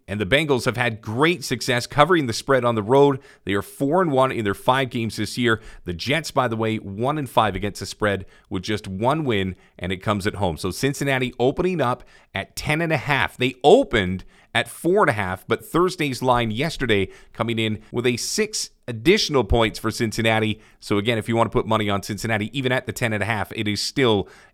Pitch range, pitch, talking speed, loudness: 105-135 Hz, 115 Hz, 225 wpm, -22 LUFS